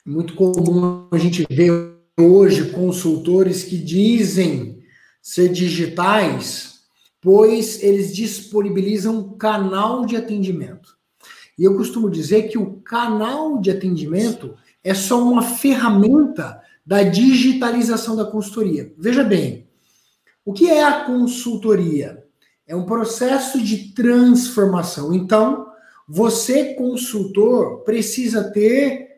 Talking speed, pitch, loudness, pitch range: 105 wpm, 210 Hz, -17 LUFS, 180-235 Hz